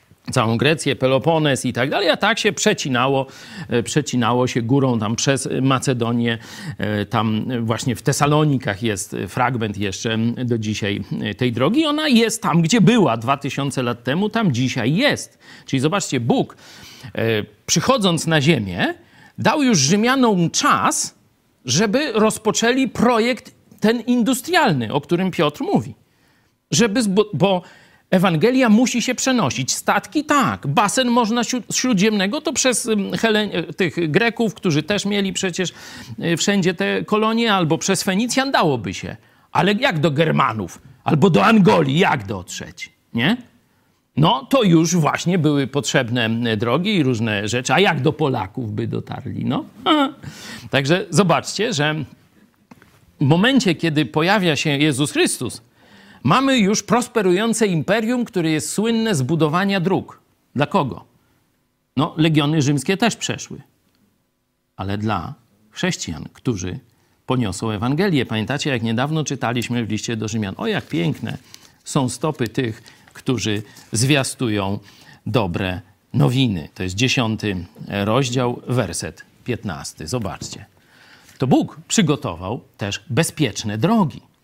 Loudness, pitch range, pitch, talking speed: -19 LUFS, 120-200 Hz, 150 Hz, 125 wpm